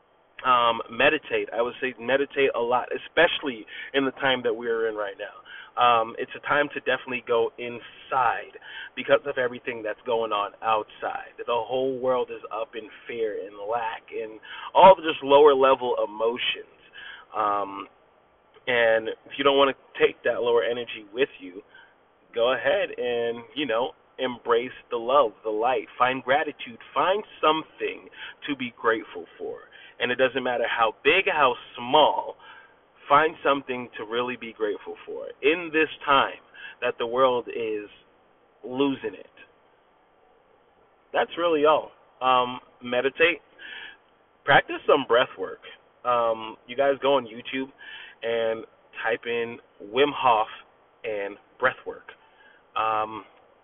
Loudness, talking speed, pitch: -24 LUFS, 145 wpm, 140 Hz